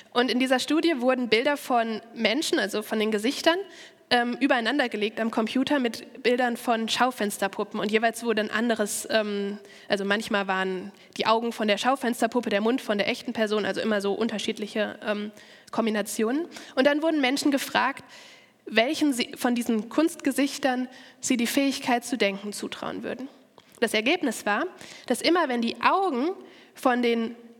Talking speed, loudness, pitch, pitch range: 160 wpm, -26 LUFS, 235 Hz, 215-270 Hz